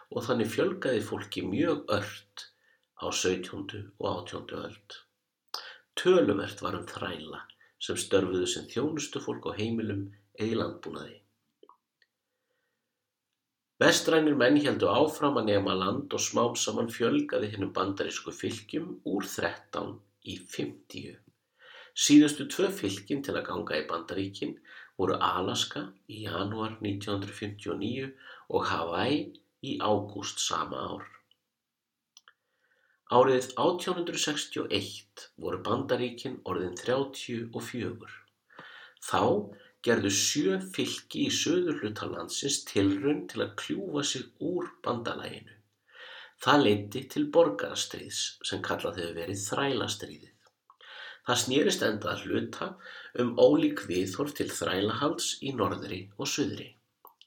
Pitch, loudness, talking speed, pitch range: 105 Hz, -30 LUFS, 110 wpm, 100-135 Hz